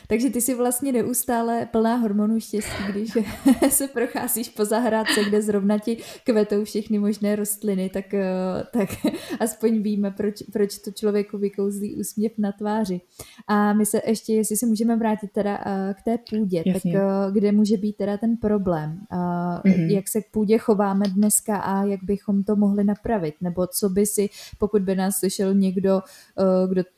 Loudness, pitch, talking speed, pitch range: -23 LUFS, 210 Hz, 160 wpm, 195-220 Hz